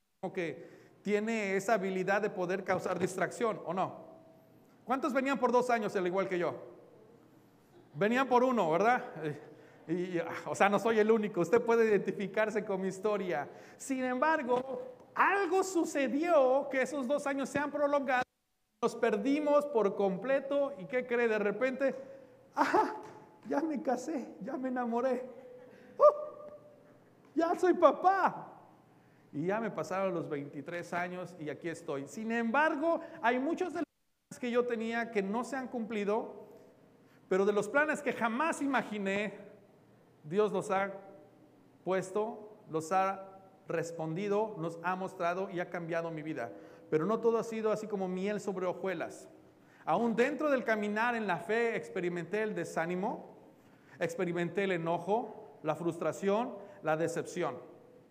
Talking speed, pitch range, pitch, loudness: 145 wpm, 185-255 Hz, 215 Hz, -33 LUFS